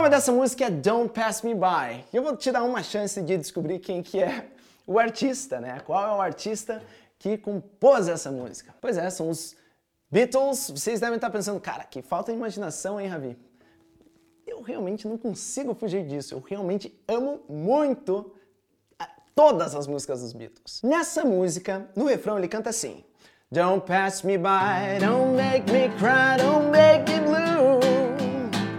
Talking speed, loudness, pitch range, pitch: 170 wpm, -24 LUFS, 185-260 Hz, 215 Hz